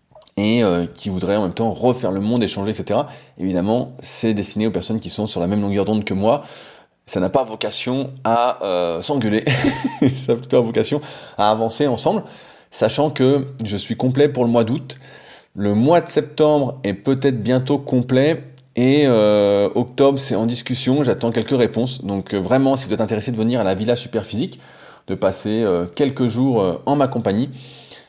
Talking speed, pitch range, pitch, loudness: 190 wpm, 105-130 Hz, 120 Hz, -19 LUFS